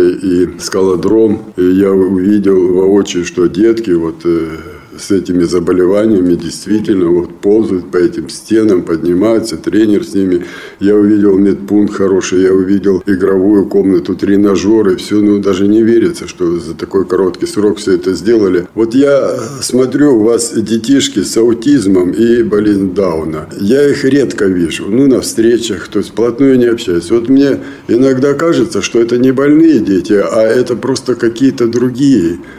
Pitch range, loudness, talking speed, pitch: 95-125 Hz, -11 LUFS, 150 wpm, 105 Hz